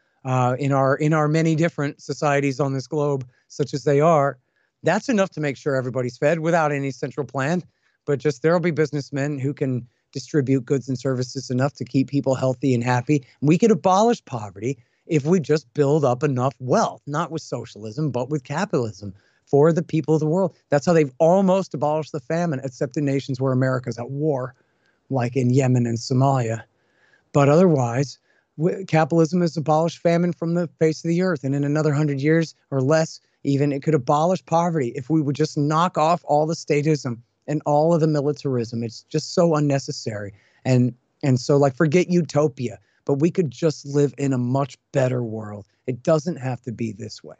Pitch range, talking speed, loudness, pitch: 130-160 Hz, 190 wpm, -22 LUFS, 145 Hz